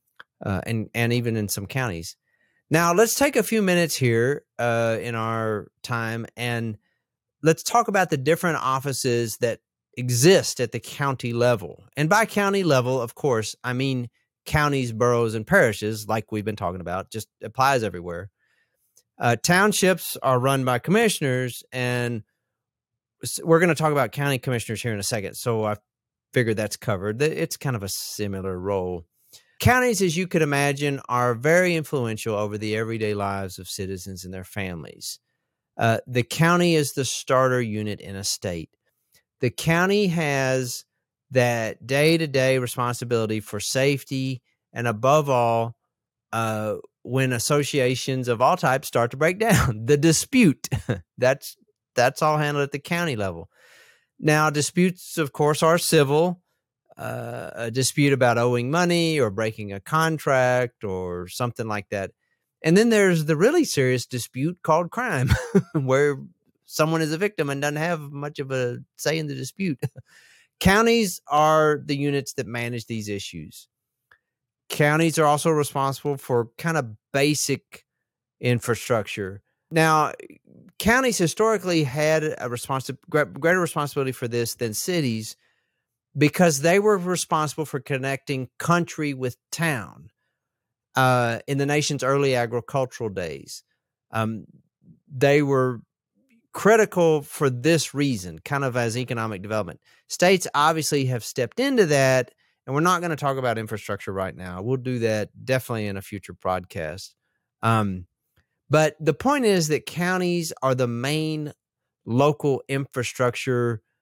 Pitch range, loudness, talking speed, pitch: 115-155 Hz, -23 LUFS, 145 wpm, 130 Hz